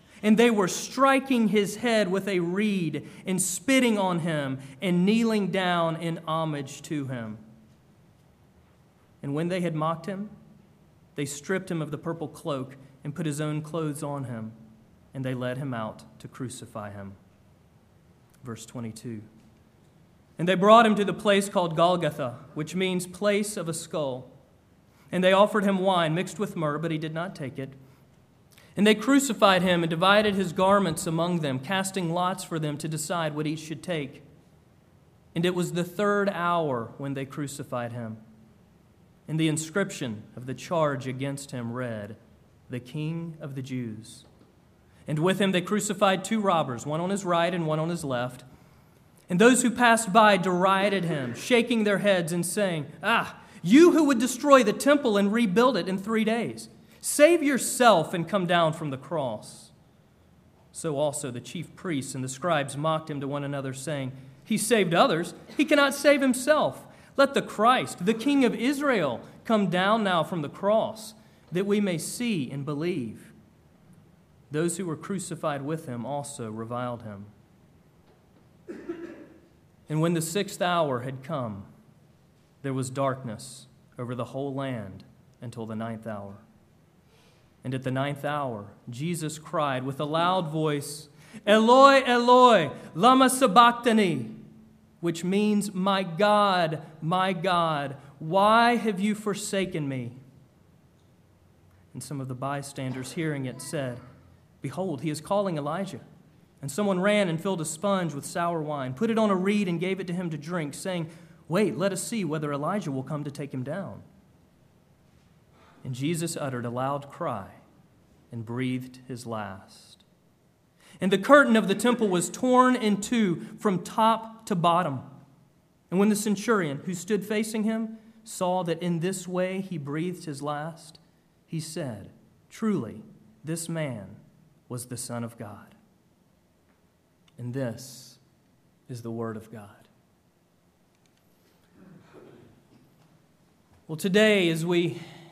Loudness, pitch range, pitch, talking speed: -26 LUFS, 135-200 Hz, 165 Hz, 155 wpm